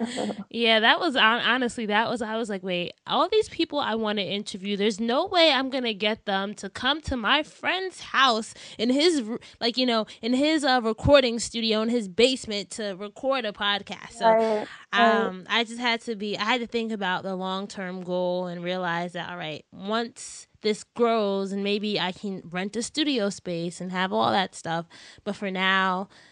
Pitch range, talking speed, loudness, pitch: 195-240 Hz, 200 wpm, -25 LUFS, 215 Hz